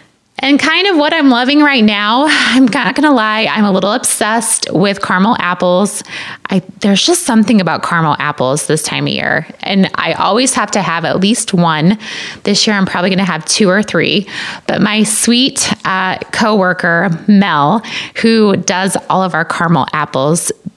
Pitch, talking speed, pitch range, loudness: 205 Hz, 175 wpm, 185-235 Hz, -11 LUFS